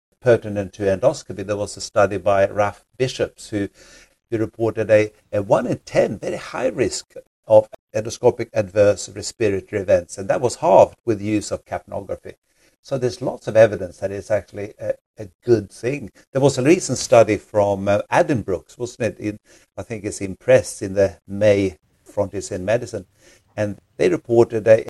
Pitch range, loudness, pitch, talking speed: 100-115 Hz, -20 LUFS, 105 Hz, 175 wpm